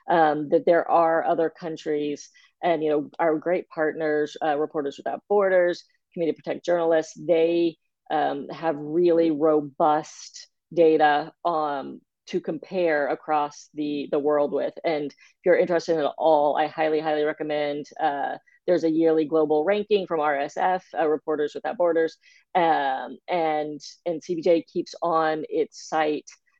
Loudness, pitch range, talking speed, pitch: -24 LUFS, 150-170 Hz, 140 wpm, 160 Hz